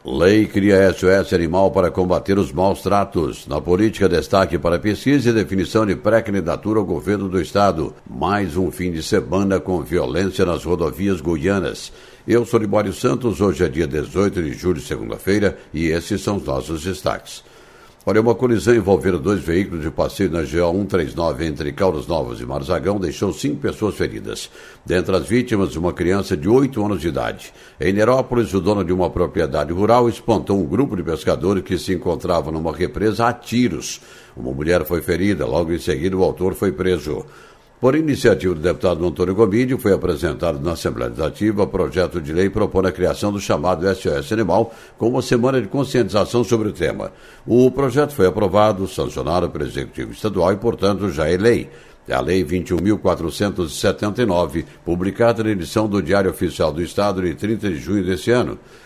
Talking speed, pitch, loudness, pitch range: 175 wpm, 95 Hz, -19 LUFS, 90-110 Hz